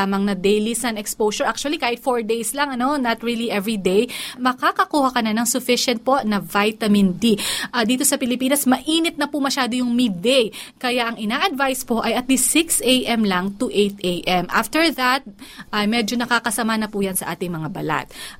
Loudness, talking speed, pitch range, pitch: -20 LUFS, 195 wpm, 210-260 Hz, 240 Hz